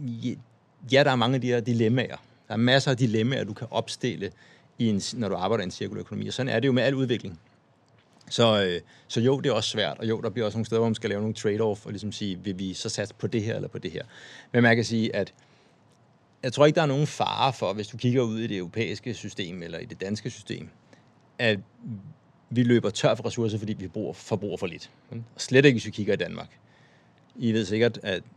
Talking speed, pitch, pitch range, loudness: 245 wpm, 115 Hz, 105-125 Hz, -26 LUFS